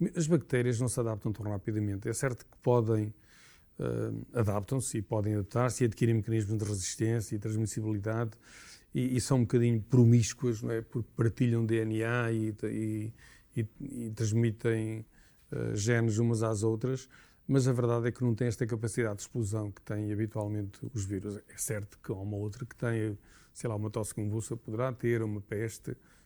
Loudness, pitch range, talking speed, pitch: -32 LUFS, 110-120 Hz, 175 wpm, 115 Hz